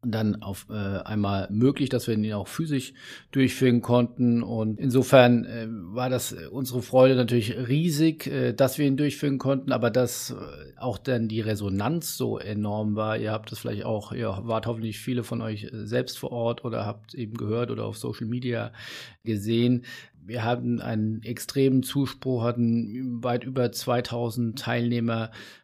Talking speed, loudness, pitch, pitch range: 155 wpm, -26 LUFS, 120 Hz, 110-125 Hz